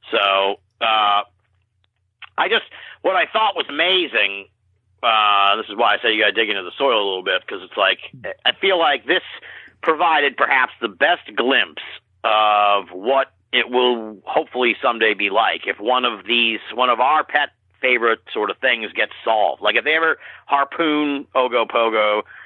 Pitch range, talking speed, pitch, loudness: 100-135 Hz, 175 wpm, 115 Hz, -18 LUFS